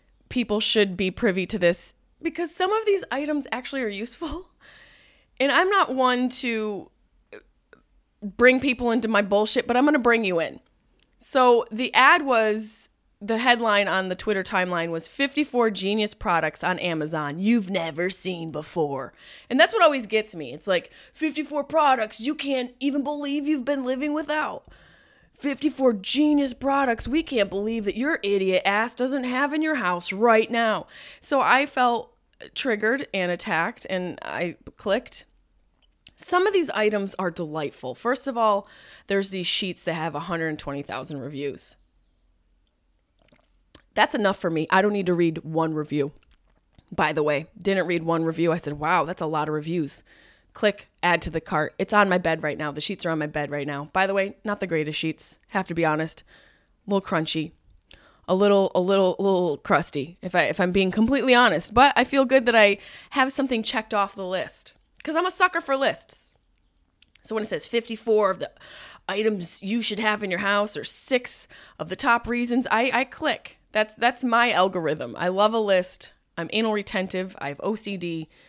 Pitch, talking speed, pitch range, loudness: 205 Hz, 185 wpm, 175-250 Hz, -24 LUFS